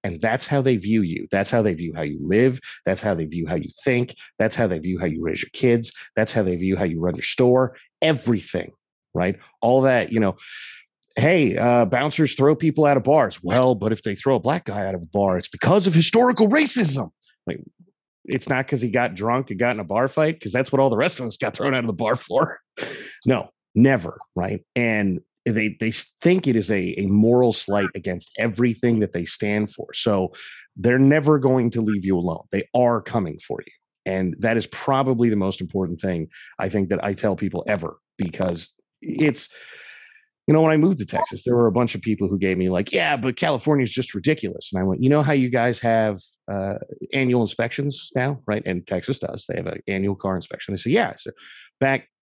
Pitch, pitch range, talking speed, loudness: 115 Hz, 100-135 Hz, 225 wpm, -21 LUFS